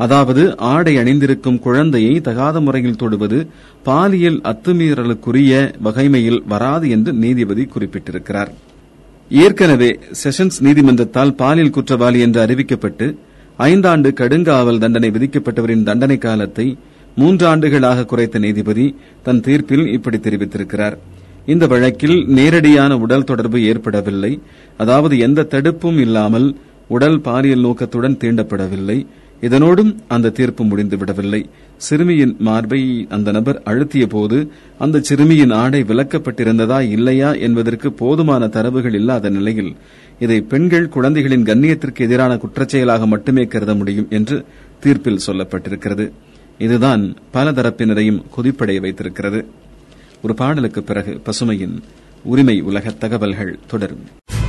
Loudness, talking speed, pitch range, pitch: -14 LUFS, 95 wpm, 110-140 Hz, 125 Hz